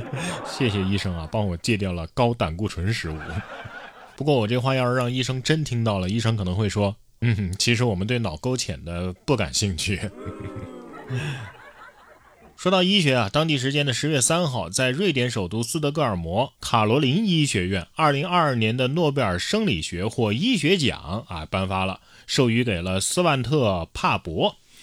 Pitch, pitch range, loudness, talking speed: 115 Hz, 95-135 Hz, -23 LUFS, 265 characters per minute